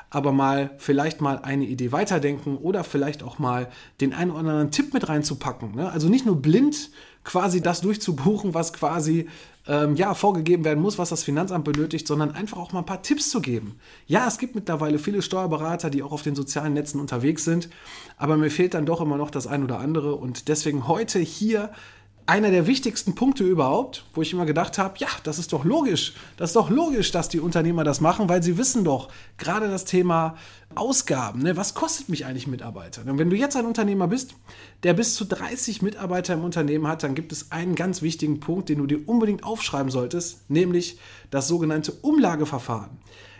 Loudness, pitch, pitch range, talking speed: -24 LUFS, 165 Hz, 145-190 Hz, 200 wpm